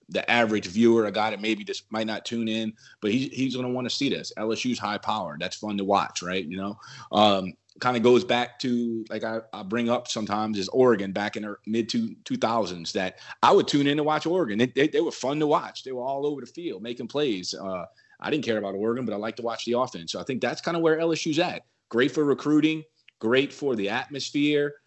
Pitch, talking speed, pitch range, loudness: 120 Hz, 250 wpm, 110-140 Hz, -26 LUFS